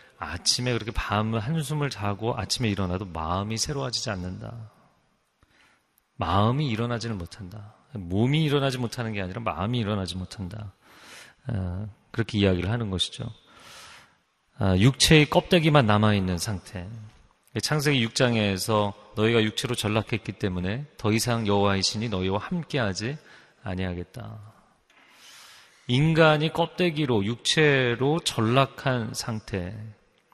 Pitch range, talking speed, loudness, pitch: 100-125 Hz, 285 characters per minute, -25 LUFS, 110 Hz